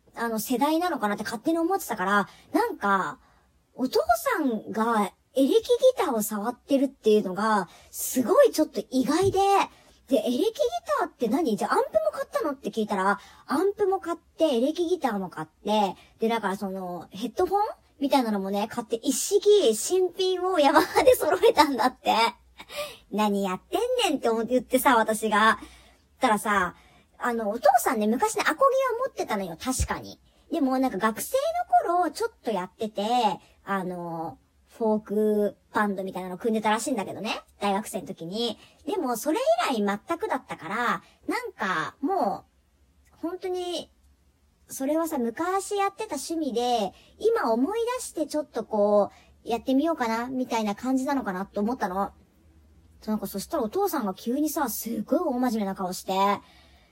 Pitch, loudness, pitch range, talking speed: 240 Hz, -26 LUFS, 205-330 Hz, 340 characters per minute